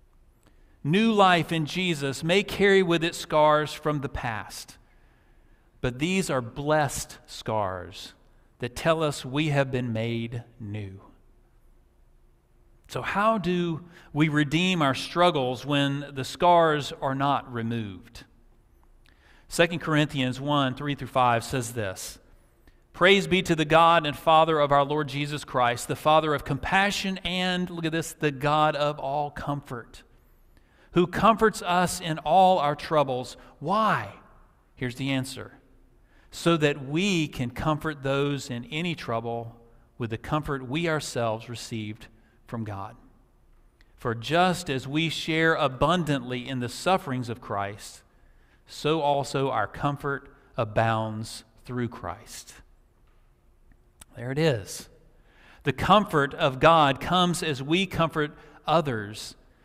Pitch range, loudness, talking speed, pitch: 120-160 Hz, -25 LUFS, 130 wpm, 145 Hz